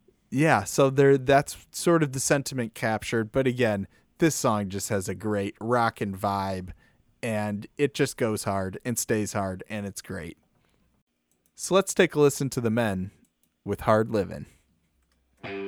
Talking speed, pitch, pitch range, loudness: 155 wpm, 110 Hz, 100-135 Hz, -26 LUFS